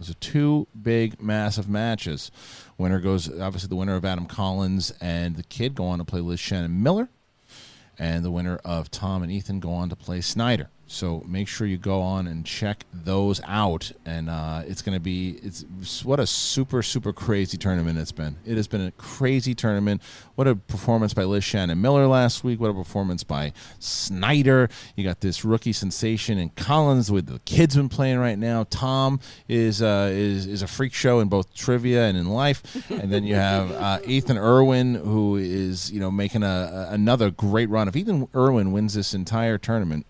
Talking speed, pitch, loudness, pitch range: 195 wpm, 100 Hz, -24 LUFS, 95-120 Hz